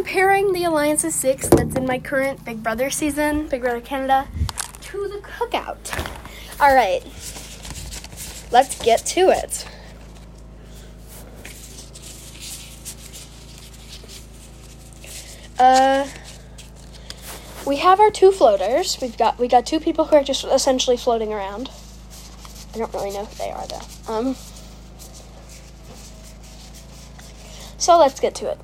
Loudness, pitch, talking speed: -19 LUFS, 235 Hz, 115 wpm